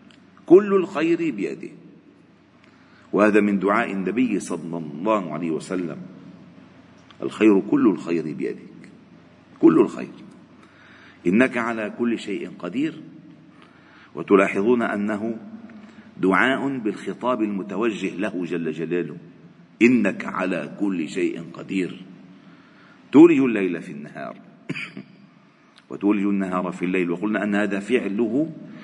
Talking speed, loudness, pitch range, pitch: 100 wpm, -22 LUFS, 95-135 Hz, 105 Hz